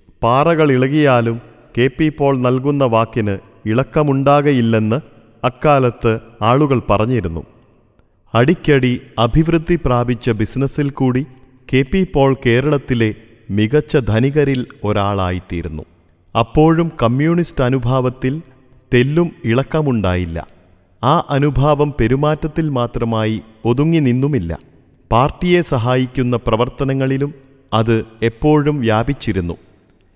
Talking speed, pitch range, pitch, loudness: 80 wpm, 115-145 Hz, 125 Hz, -16 LUFS